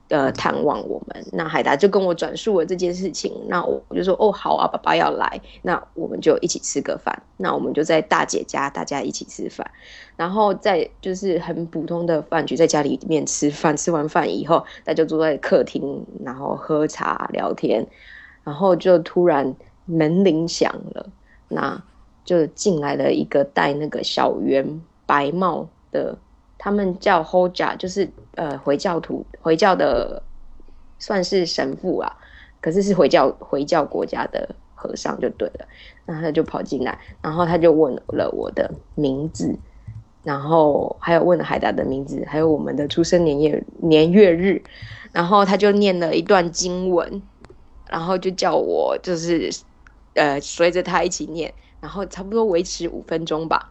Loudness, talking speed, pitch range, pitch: -20 LUFS, 245 characters per minute, 155-185 Hz, 170 Hz